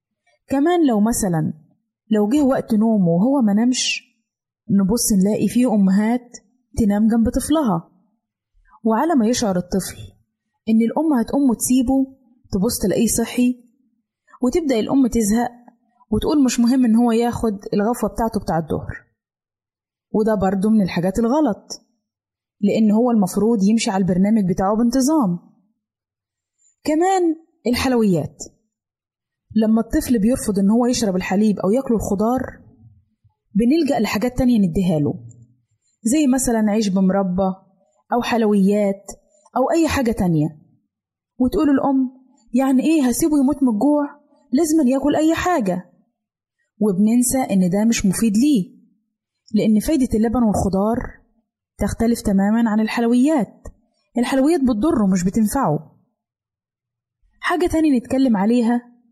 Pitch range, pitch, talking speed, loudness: 200-255 Hz, 225 Hz, 115 wpm, -18 LUFS